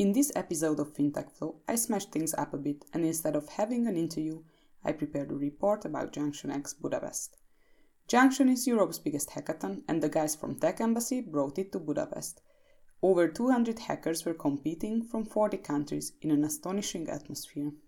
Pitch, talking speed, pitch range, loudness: 165 Hz, 175 wpm, 150-225 Hz, -31 LUFS